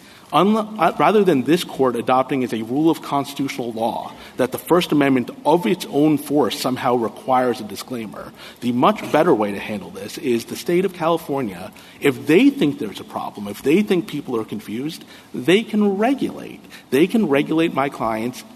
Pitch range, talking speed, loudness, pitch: 120-165 Hz, 185 wpm, -20 LUFS, 135 Hz